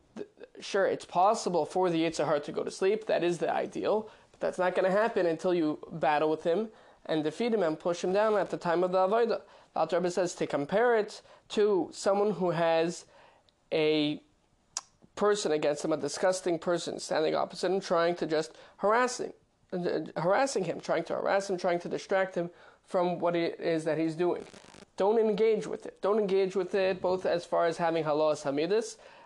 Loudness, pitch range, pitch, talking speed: -29 LUFS, 165-205 Hz, 180 Hz, 195 wpm